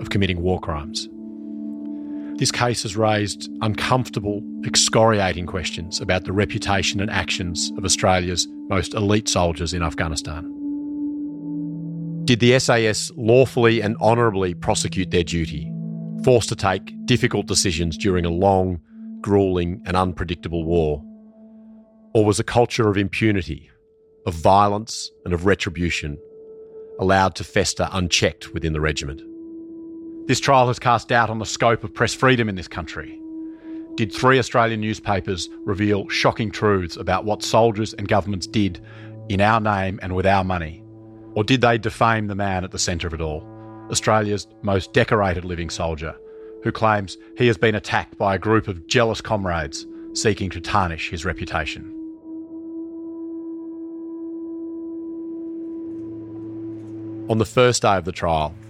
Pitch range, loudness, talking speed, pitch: 95-125 Hz, -21 LUFS, 140 wpm, 110 Hz